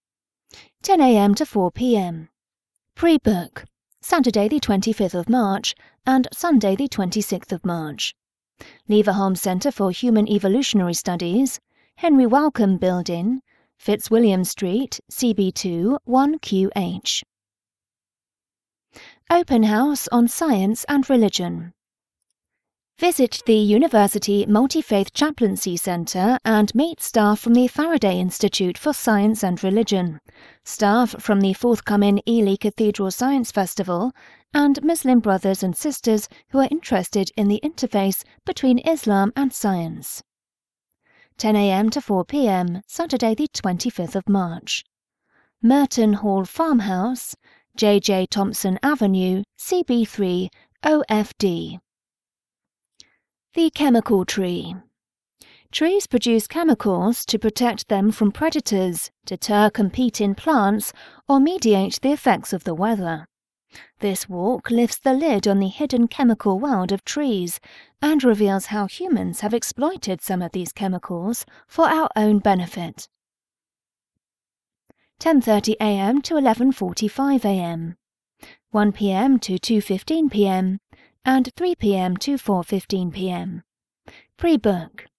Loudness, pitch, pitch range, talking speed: -20 LUFS, 210 Hz, 190-255 Hz, 110 wpm